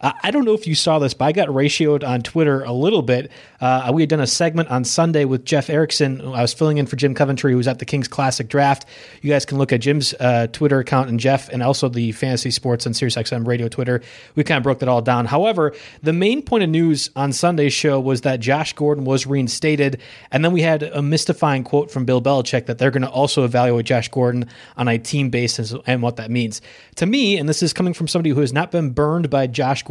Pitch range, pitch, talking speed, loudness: 125-155 Hz, 140 Hz, 255 wpm, -18 LUFS